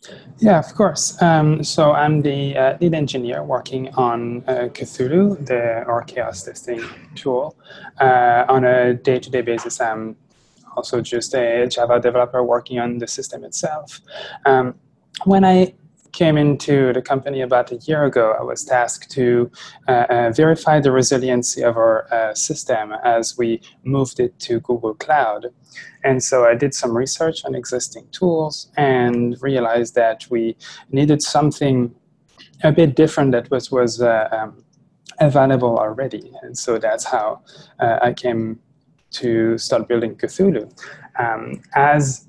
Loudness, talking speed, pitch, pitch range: -18 LUFS, 150 wpm, 130 Hz, 120-150 Hz